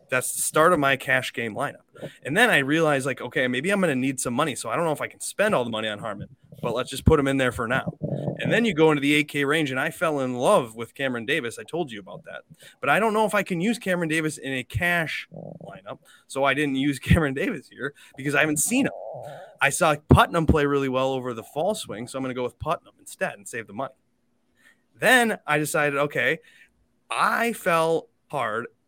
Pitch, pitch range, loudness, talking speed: 145 Hz, 130-165 Hz, -23 LUFS, 245 wpm